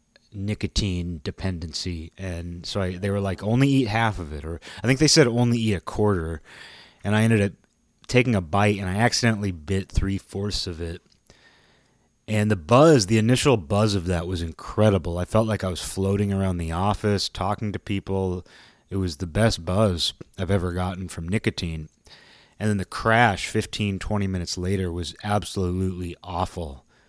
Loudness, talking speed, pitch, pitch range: -24 LUFS, 175 wpm, 95 Hz, 90-105 Hz